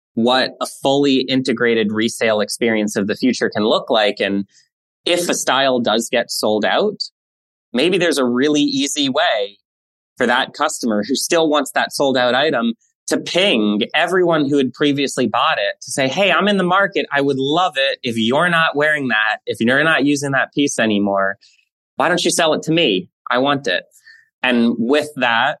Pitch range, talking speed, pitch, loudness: 110-155 Hz, 190 wpm, 130 Hz, -17 LUFS